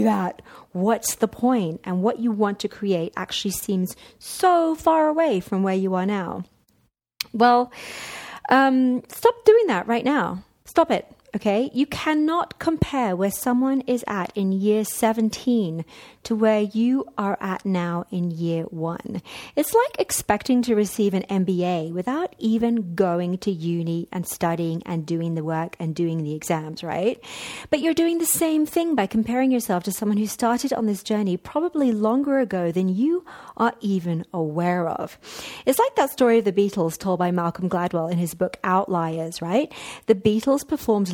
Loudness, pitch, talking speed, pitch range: -23 LUFS, 210 Hz, 170 wpm, 180-250 Hz